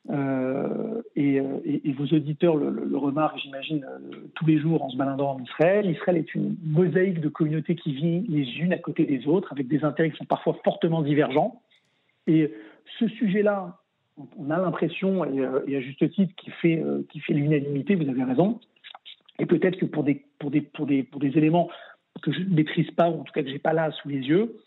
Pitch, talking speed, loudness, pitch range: 155 Hz, 220 wpm, -25 LUFS, 140-175 Hz